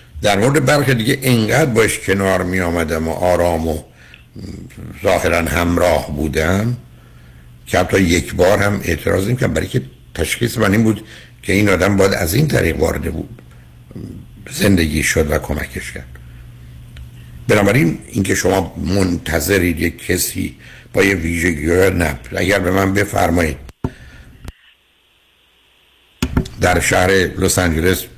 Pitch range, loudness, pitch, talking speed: 80-100 Hz, -16 LUFS, 90 Hz, 130 wpm